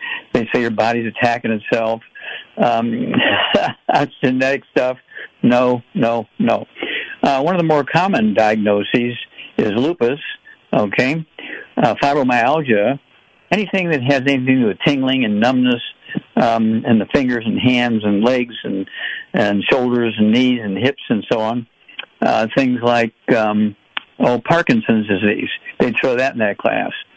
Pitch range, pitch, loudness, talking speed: 115-140 Hz, 120 Hz, -17 LUFS, 145 wpm